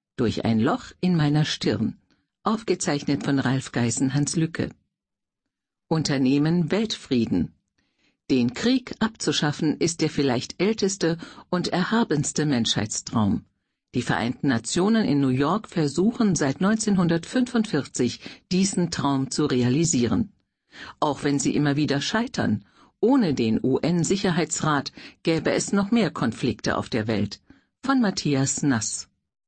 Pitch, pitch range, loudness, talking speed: 155 Hz, 135-190 Hz, -24 LUFS, 115 wpm